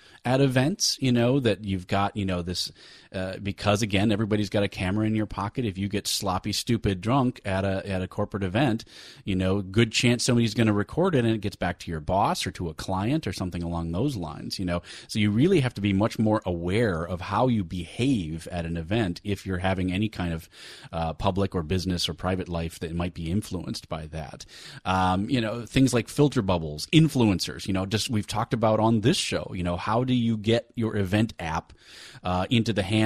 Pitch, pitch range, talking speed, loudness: 100 Hz, 90-115 Hz, 225 wpm, -26 LUFS